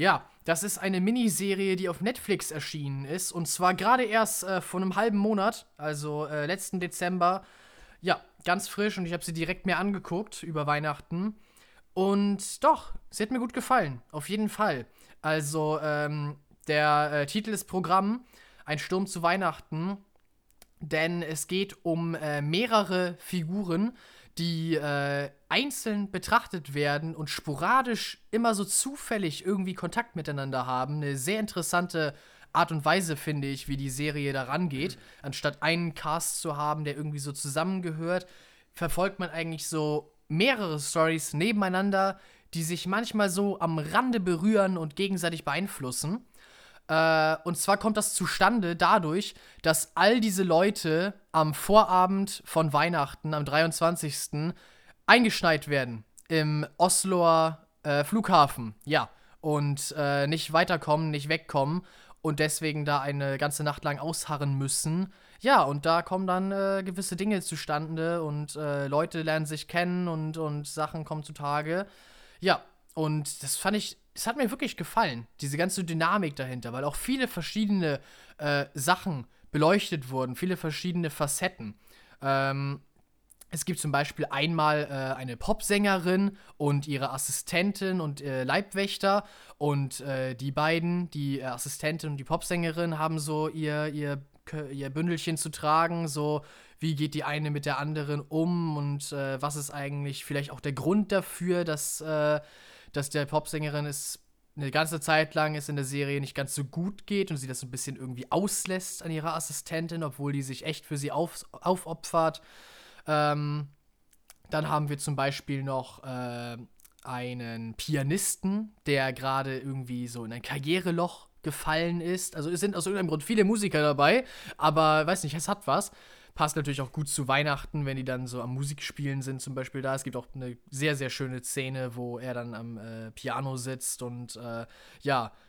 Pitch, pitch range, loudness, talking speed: 155 Hz, 145-185 Hz, -29 LUFS, 155 wpm